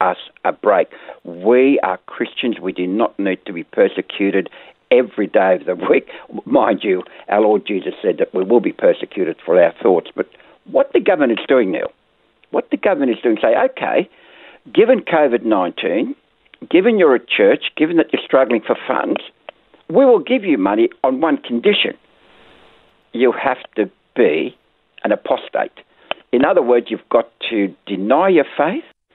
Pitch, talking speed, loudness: 135 Hz, 170 wpm, -16 LUFS